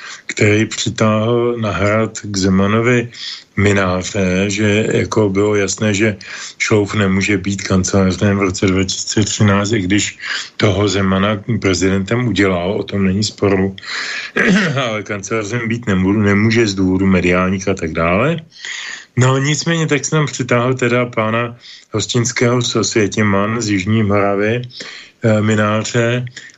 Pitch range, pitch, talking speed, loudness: 100-115 Hz, 105 Hz, 120 wpm, -15 LUFS